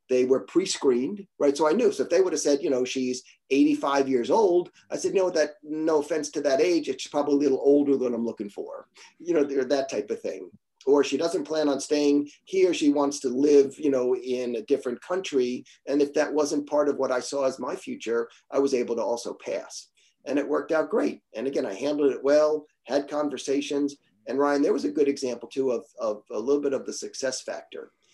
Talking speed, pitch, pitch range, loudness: 230 wpm, 145 Hz, 135-190 Hz, -25 LUFS